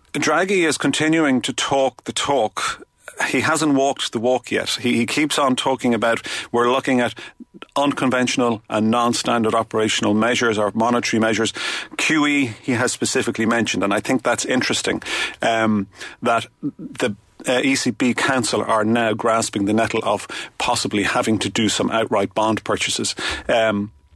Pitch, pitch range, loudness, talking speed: 120 Hz, 110-130 Hz, -19 LUFS, 150 wpm